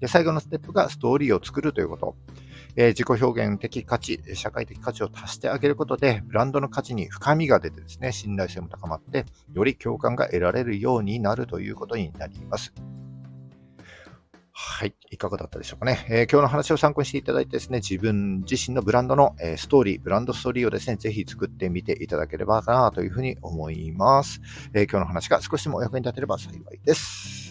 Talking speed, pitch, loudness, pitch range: 440 characters per minute, 115 Hz, -25 LUFS, 95-130 Hz